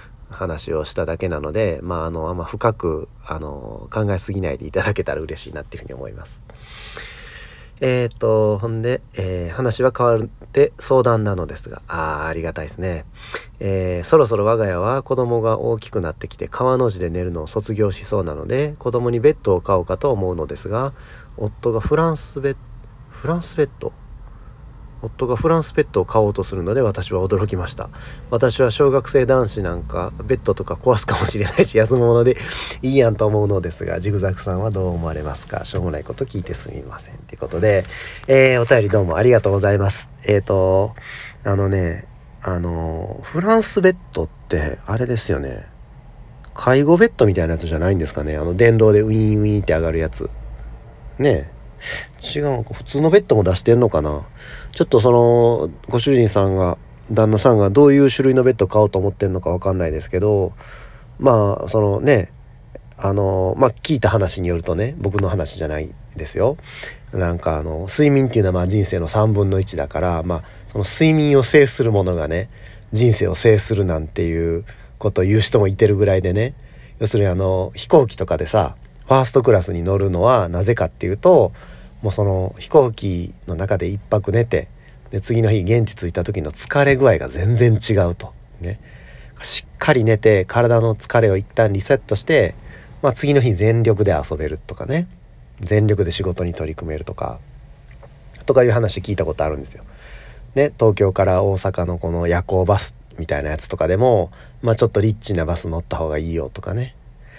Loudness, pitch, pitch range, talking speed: -18 LUFS, 105 Hz, 90-120 Hz, 375 characters per minute